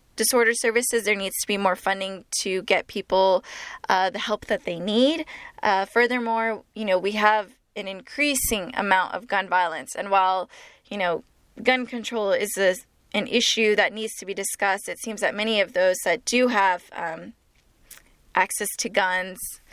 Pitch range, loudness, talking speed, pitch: 190-230 Hz, -23 LUFS, 175 wpm, 205 Hz